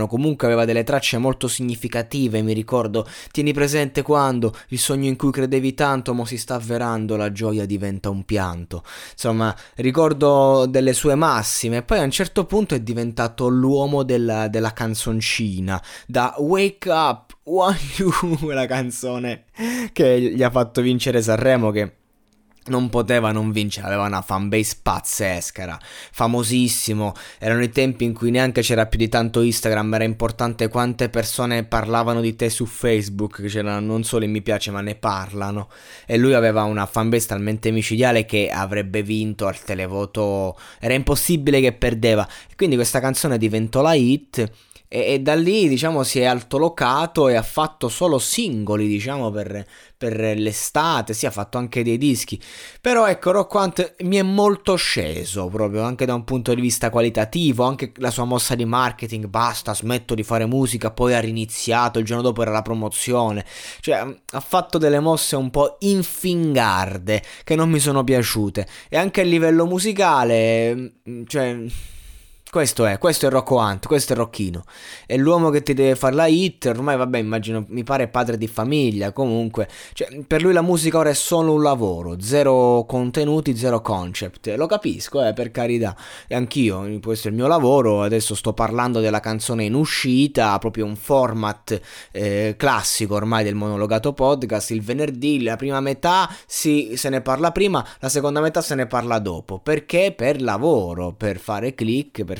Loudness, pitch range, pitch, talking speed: -20 LUFS, 110-140 Hz, 120 Hz, 170 wpm